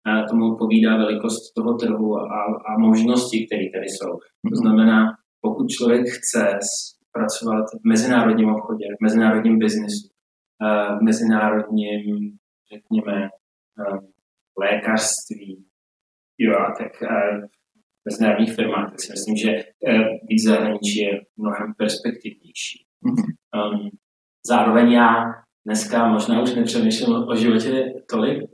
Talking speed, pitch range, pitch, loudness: 105 wpm, 105-120 Hz, 110 Hz, -20 LUFS